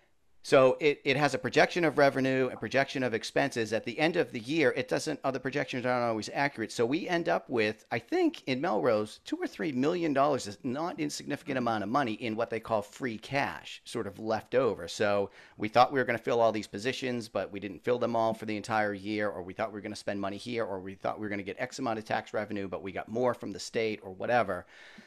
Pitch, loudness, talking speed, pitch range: 115 Hz, -30 LUFS, 250 wpm, 105-135 Hz